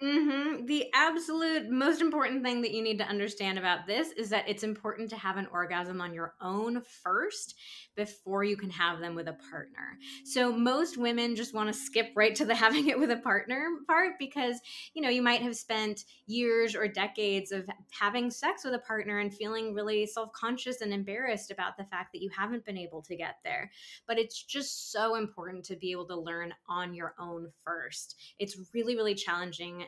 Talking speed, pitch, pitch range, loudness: 200 wpm, 215 Hz, 190-245 Hz, -32 LUFS